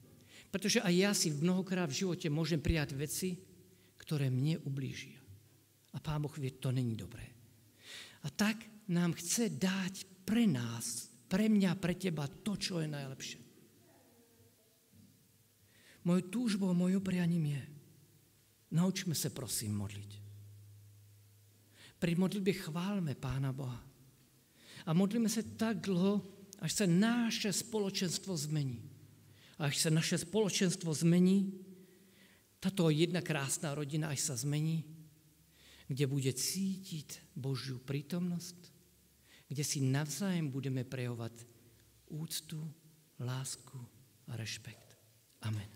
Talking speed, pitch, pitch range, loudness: 115 wpm, 150 Hz, 120-180 Hz, -36 LUFS